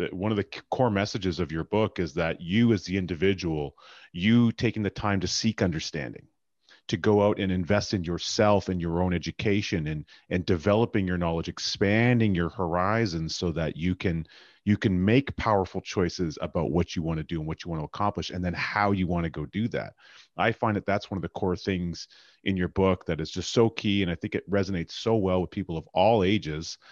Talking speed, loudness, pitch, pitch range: 220 wpm, -27 LUFS, 95 Hz, 85-105 Hz